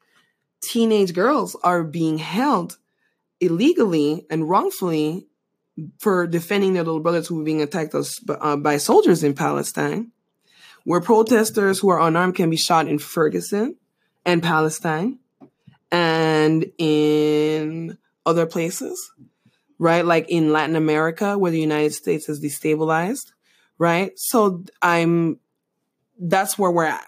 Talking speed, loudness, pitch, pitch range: 120 wpm, -20 LUFS, 170 Hz, 155-195 Hz